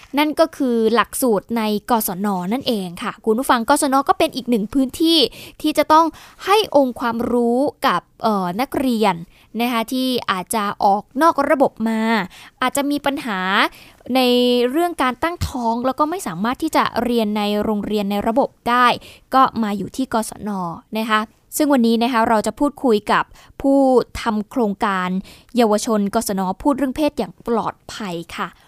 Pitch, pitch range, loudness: 235 Hz, 215-275 Hz, -19 LUFS